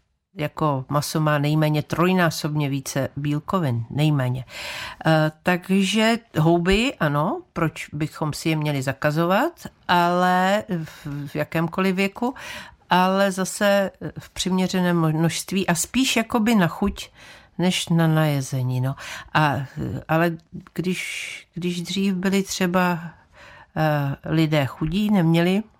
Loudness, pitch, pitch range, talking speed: -22 LUFS, 170 Hz, 150-190 Hz, 105 wpm